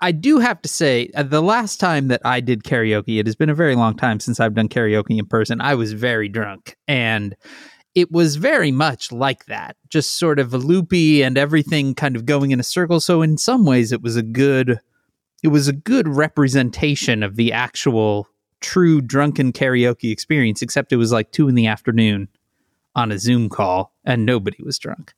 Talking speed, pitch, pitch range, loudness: 205 wpm, 130 Hz, 115-150 Hz, -18 LUFS